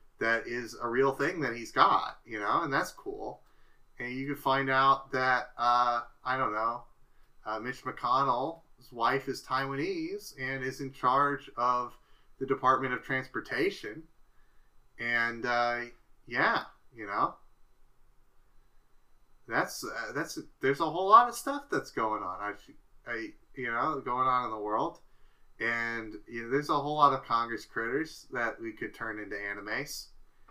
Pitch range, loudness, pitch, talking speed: 115-135 Hz, -30 LUFS, 130 Hz, 155 wpm